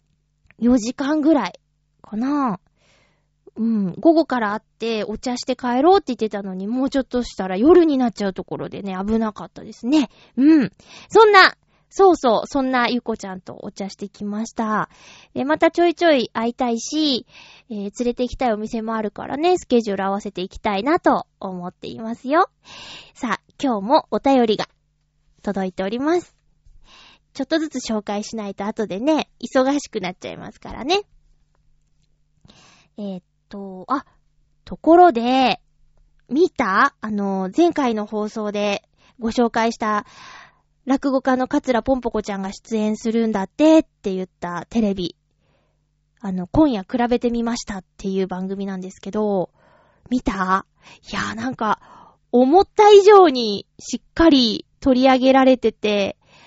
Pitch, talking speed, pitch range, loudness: 225 Hz, 305 characters per minute, 195-265 Hz, -19 LUFS